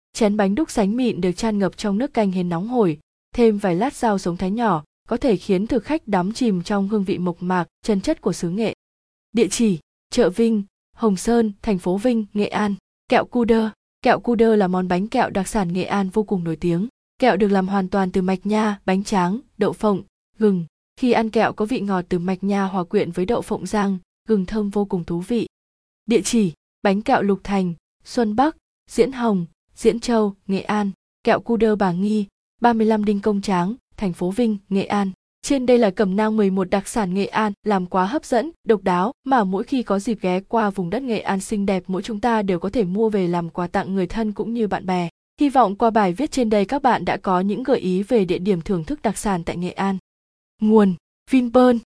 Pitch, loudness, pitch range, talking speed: 205 Hz, -21 LUFS, 190-225 Hz, 230 wpm